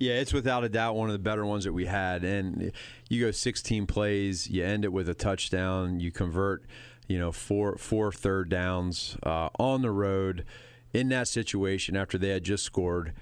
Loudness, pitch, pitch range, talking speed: -30 LUFS, 100 Hz, 95-110 Hz, 200 wpm